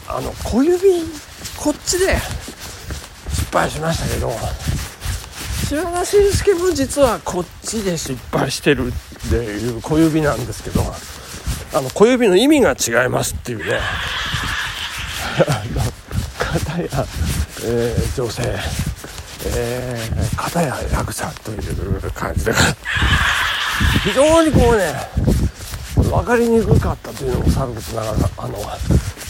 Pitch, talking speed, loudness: 135 Hz, 210 characters per minute, -18 LUFS